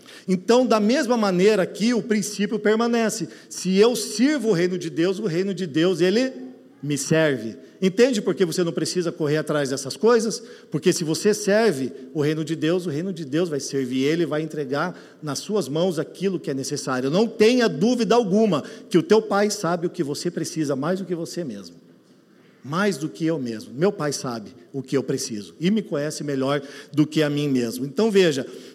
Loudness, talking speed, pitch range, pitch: -22 LUFS, 200 wpm, 145-210 Hz, 175 Hz